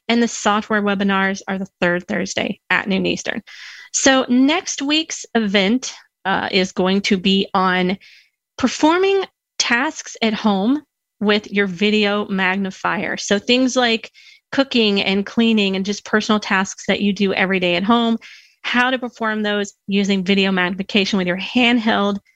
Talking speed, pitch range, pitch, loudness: 150 wpm, 195-240 Hz, 205 Hz, -18 LUFS